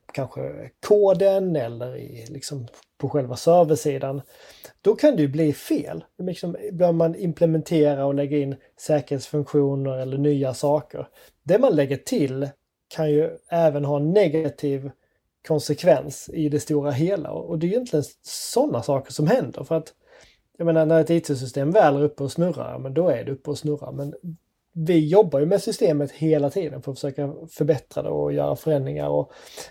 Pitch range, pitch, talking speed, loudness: 140-165 Hz, 150 Hz, 170 wpm, -22 LUFS